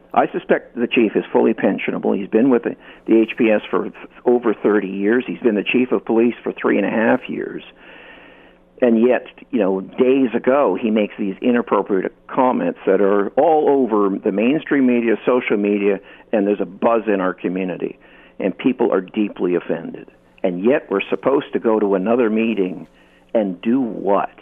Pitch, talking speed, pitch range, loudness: 105 Hz, 180 wpm, 100-120 Hz, -18 LUFS